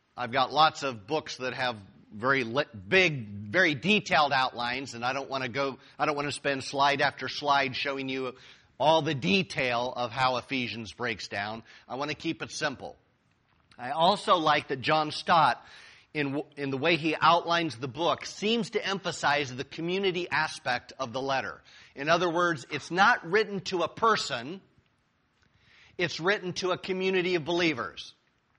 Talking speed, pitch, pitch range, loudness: 160 wpm, 145 Hz, 130-170 Hz, -28 LUFS